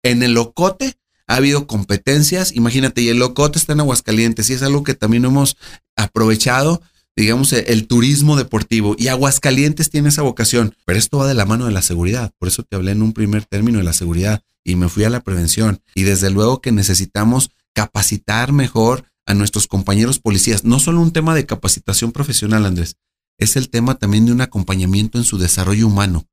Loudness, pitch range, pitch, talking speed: -15 LUFS, 105-130 Hz, 115 Hz, 195 wpm